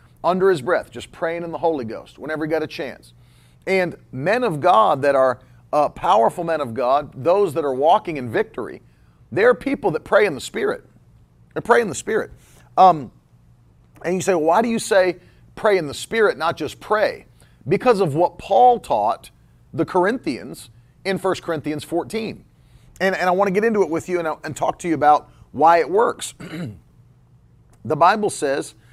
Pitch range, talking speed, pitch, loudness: 130-195 Hz, 195 wpm, 170 Hz, -20 LUFS